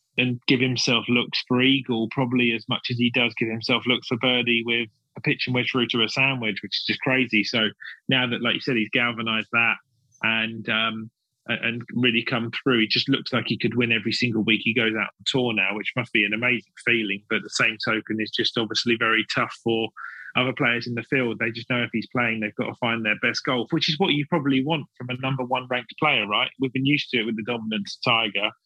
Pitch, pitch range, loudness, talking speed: 120 Hz, 115-125 Hz, -23 LUFS, 245 wpm